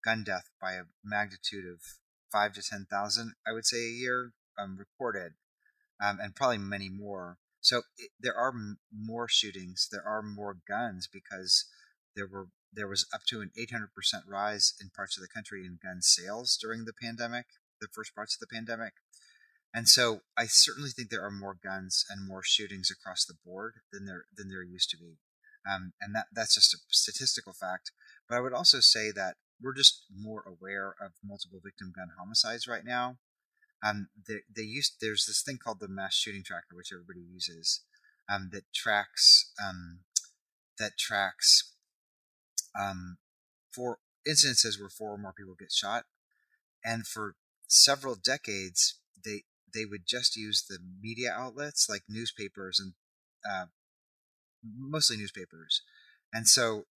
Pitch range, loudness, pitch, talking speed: 95-115 Hz, -28 LUFS, 105 Hz, 170 wpm